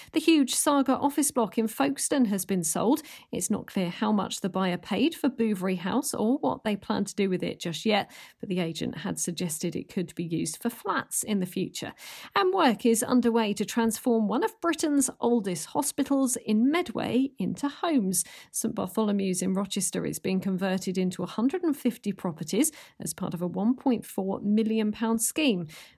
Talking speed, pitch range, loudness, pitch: 180 wpm, 190-260 Hz, -27 LUFS, 220 Hz